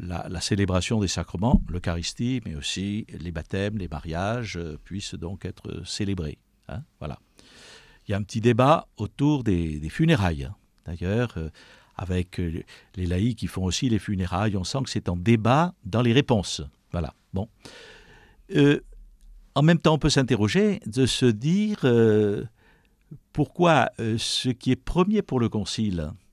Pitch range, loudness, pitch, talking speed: 90-130 Hz, -25 LUFS, 105 Hz, 155 wpm